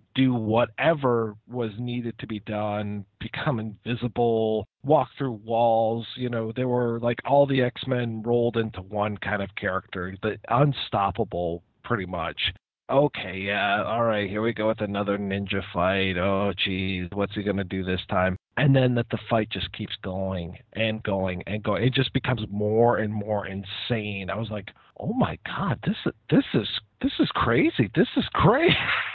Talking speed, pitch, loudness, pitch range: 175 wpm, 110 Hz, -25 LUFS, 100-120 Hz